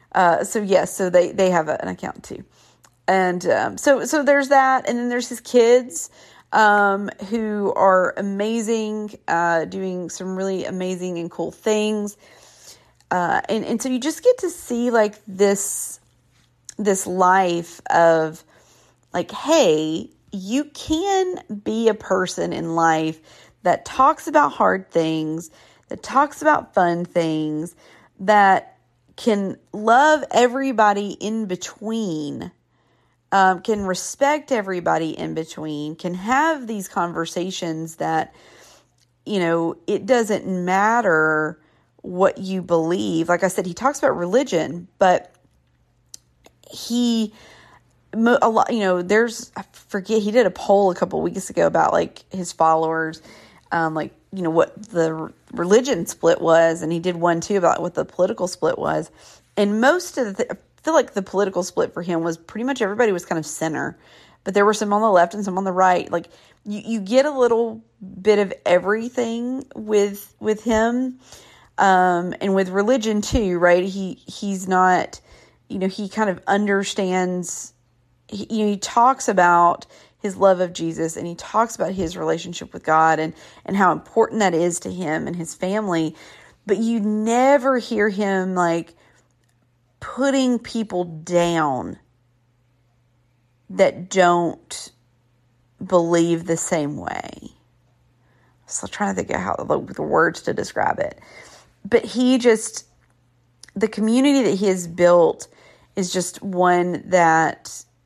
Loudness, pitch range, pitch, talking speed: -20 LUFS, 165-220 Hz, 190 Hz, 150 wpm